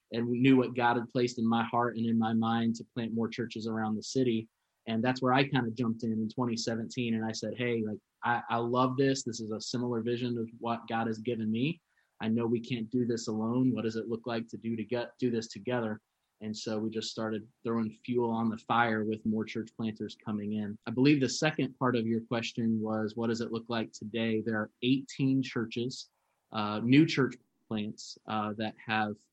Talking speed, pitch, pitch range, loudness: 230 wpm, 115 Hz, 110-125 Hz, -32 LUFS